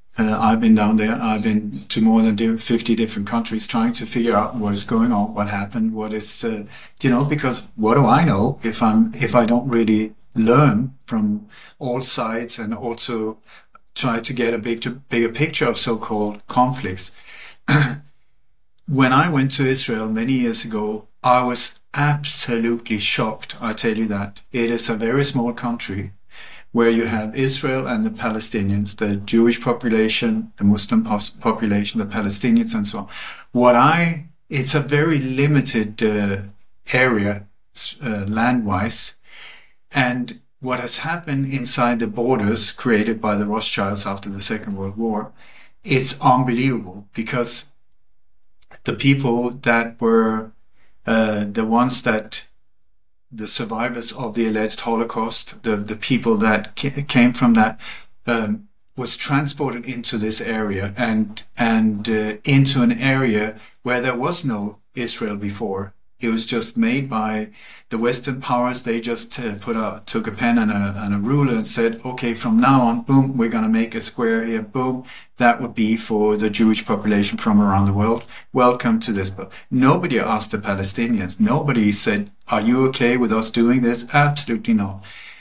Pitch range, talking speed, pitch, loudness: 110-130 Hz, 160 wpm, 115 Hz, -18 LUFS